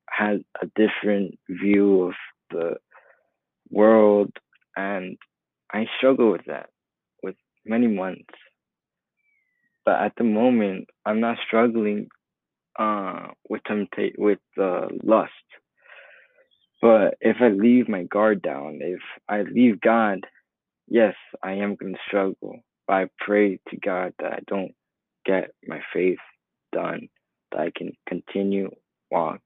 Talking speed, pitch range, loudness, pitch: 125 wpm, 95-115 Hz, -23 LUFS, 105 Hz